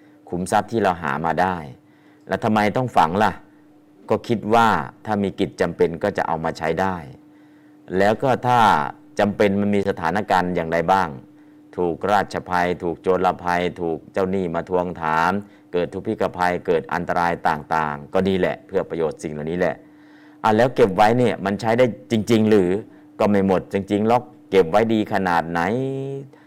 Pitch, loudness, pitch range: 100 Hz, -21 LUFS, 90-115 Hz